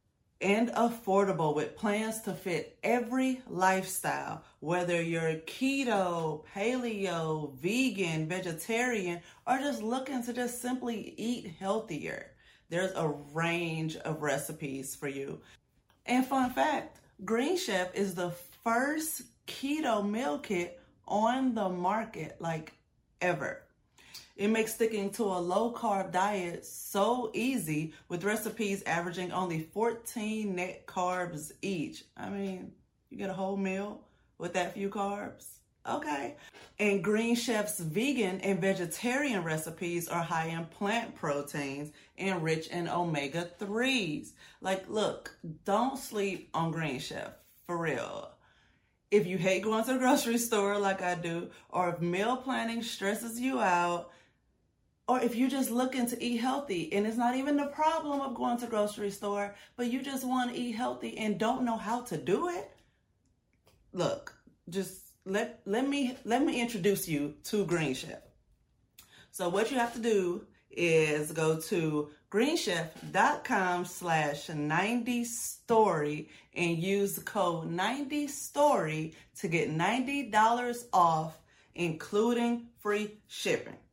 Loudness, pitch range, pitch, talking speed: -32 LUFS, 170-235 Hz, 200 Hz, 135 wpm